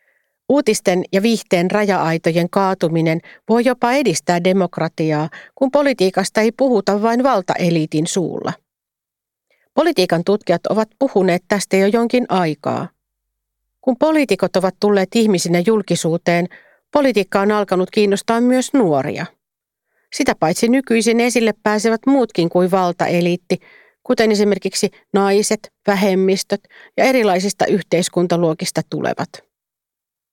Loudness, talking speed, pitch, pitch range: -17 LUFS, 105 wpm, 200 Hz, 175-230 Hz